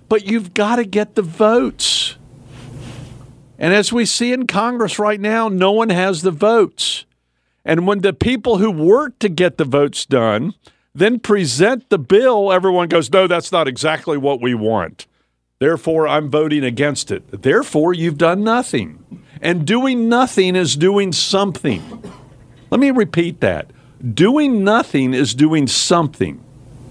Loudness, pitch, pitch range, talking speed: -16 LUFS, 175 Hz, 140-210 Hz, 150 wpm